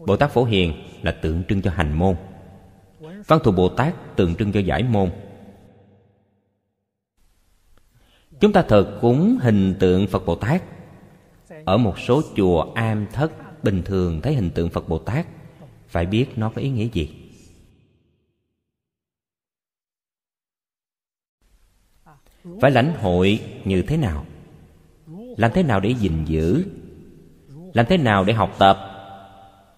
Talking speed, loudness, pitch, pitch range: 135 wpm, -20 LUFS, 100 Hz, 95-125 Hz